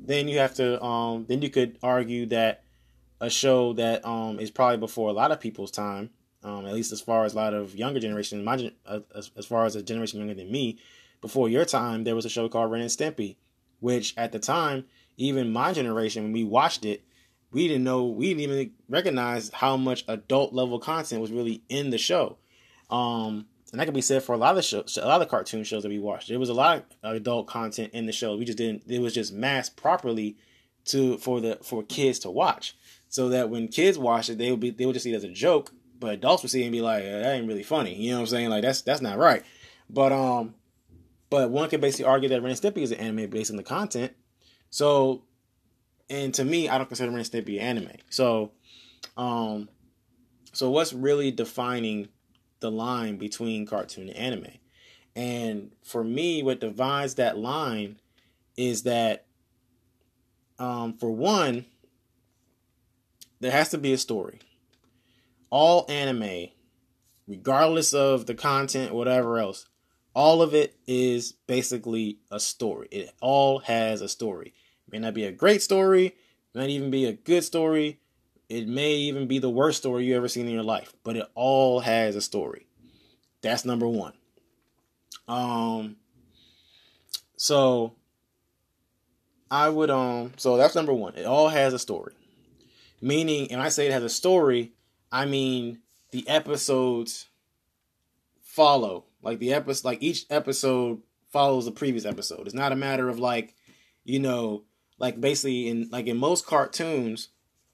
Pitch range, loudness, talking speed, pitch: 115-130 Hz, -26 LUFS, 185 wpm, 120 Hz